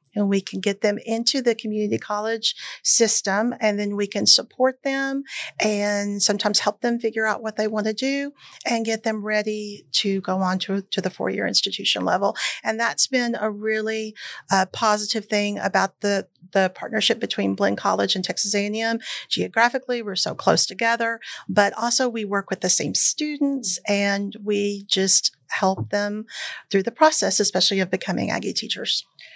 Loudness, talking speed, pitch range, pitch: -21 LUFS, 170 wpm, 200-230 Hz, 210 Hz